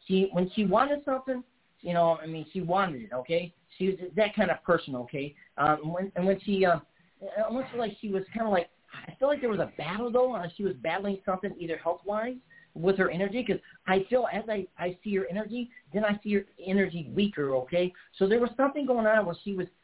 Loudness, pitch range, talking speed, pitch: -29 LUFS, 175-220 Hz, 225 wpm, 195 Hz